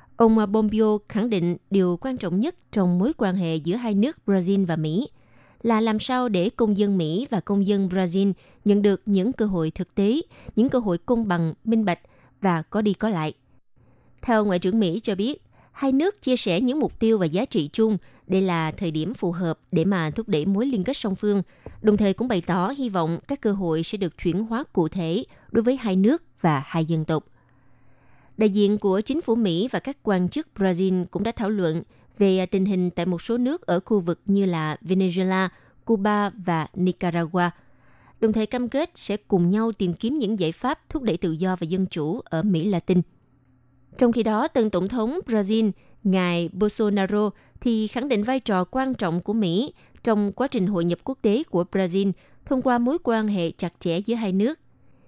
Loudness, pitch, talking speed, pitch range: -23 LUFS, 195 Hz, 210 wpm, 175-225 Hz